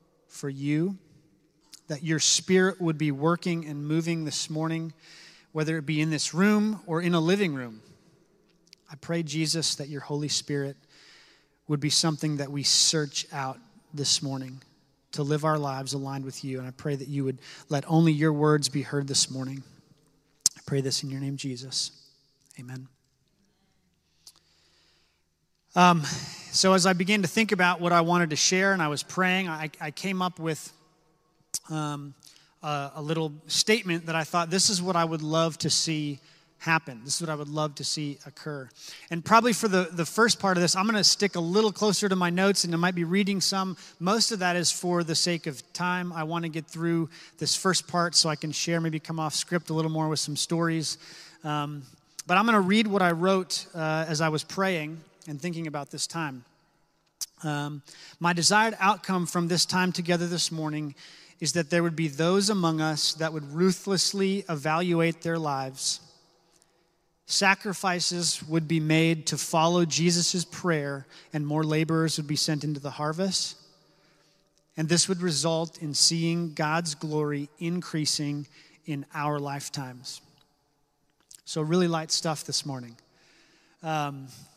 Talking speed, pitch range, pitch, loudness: 180 wpm, 150-175 Hz, 160 Hz, -26 LUFS